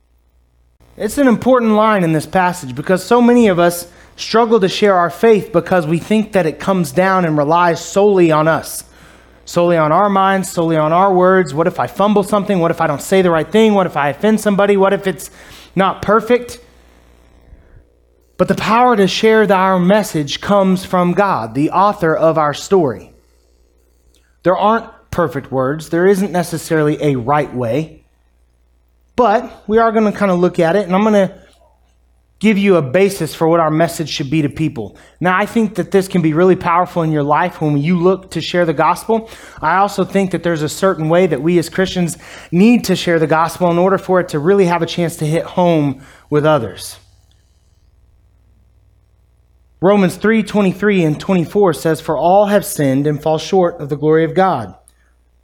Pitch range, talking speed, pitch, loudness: 145-195 Hz, 195 wpm, 170 Hz, -14 LUFS